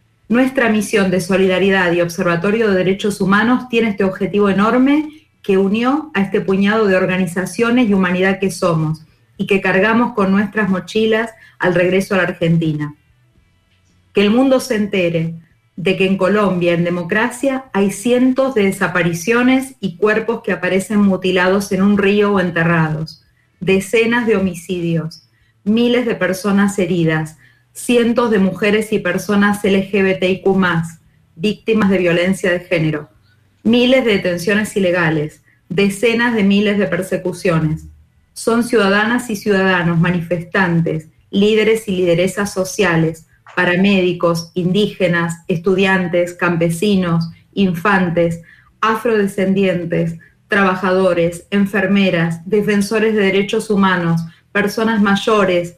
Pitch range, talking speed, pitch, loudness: 175-210 Hz, 120 wpm, 190 Hz, -15 LUFS